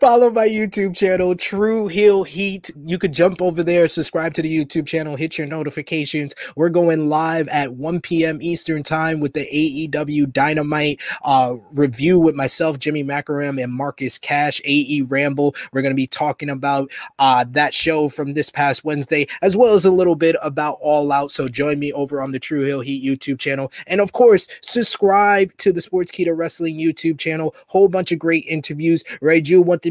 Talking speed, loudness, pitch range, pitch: 190 wpm, -18 LUFS, 145-175 Hz, 155 Hz